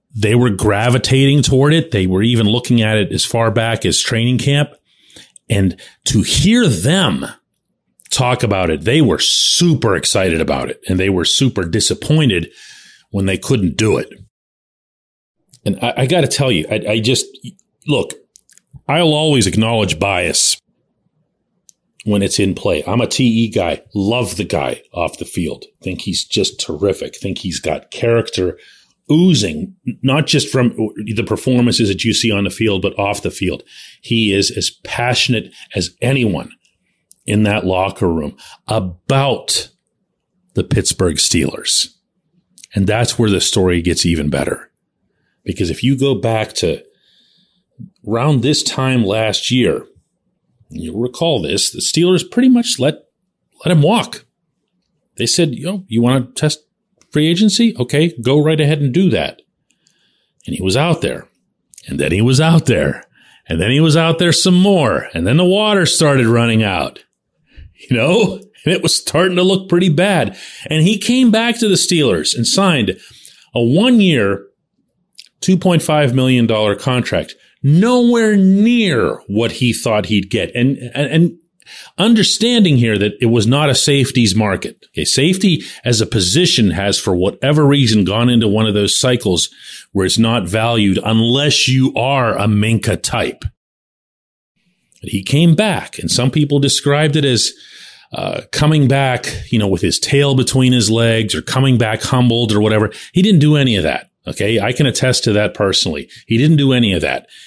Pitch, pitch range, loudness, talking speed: 125 Hz, 110-155 Hz, -14 LUFS, 165 wpm